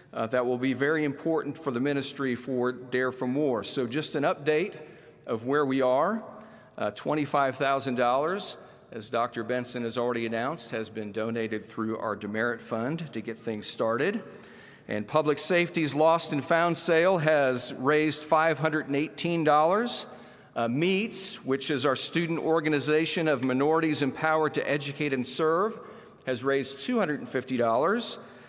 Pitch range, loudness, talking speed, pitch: 125-155 Hz, -27 LUFS, 140 wpm, 140 Hz